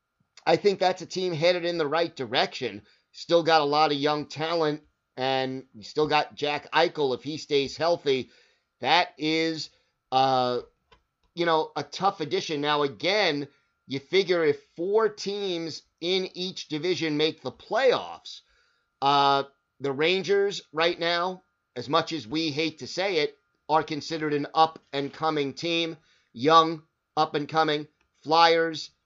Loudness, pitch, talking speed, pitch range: -26 LUFS, 155 Hz, 140 wpm, 145-170 Hz